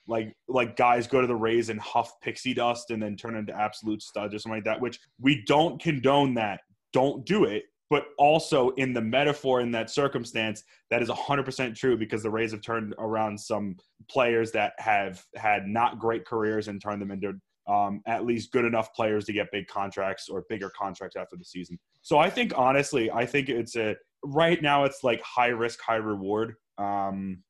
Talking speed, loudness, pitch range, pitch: 205 wpm, -27 LUFS, 105-125 Hz, 115 Hz